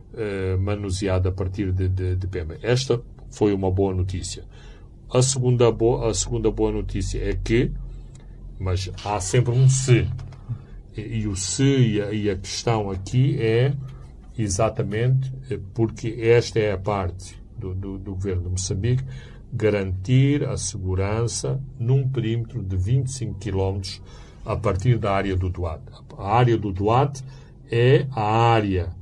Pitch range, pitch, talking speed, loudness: 95-120 Hz, 110 Hz, 145 wpm, -23 LUFS